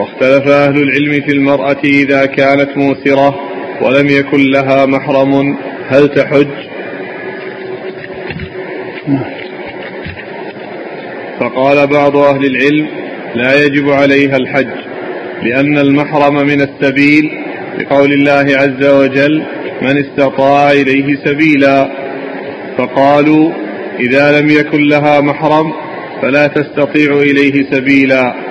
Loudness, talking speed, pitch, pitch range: -10 LUFS, 95 wpm, 140 Hz, 135-145 Hz